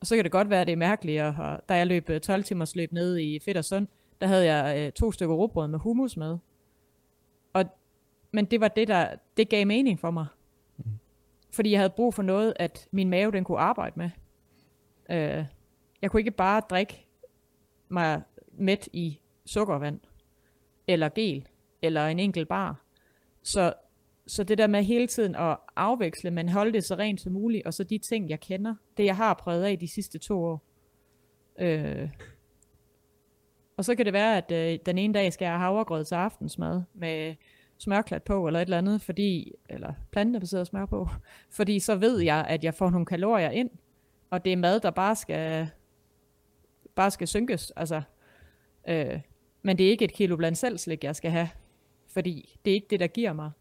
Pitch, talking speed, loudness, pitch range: 185 Hz, 195 wpm, -28 LUFS, 165-205 Hz